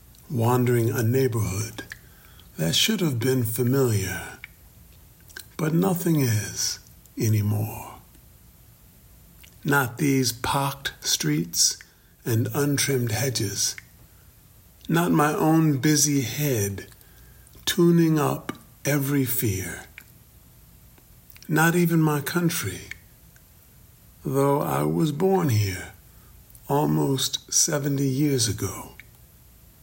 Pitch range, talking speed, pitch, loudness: 115-145 Hz, 80 wpm, 130 Hz, -23 LUFS